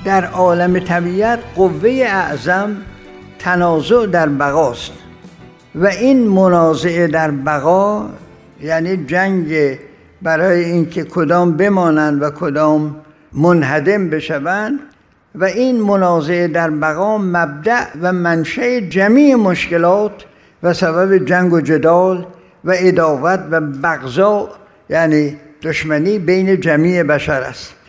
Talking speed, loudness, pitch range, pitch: 105 wpm, -14 LUFS, 160-190 Hz, 175 Hz